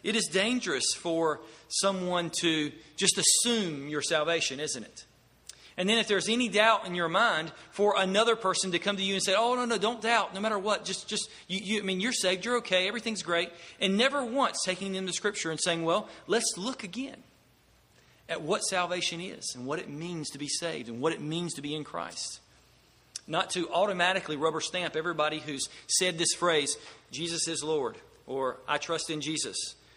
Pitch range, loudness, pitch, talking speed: 160-205 Hz, -29 LUFS, 180 Hz, 200 wpm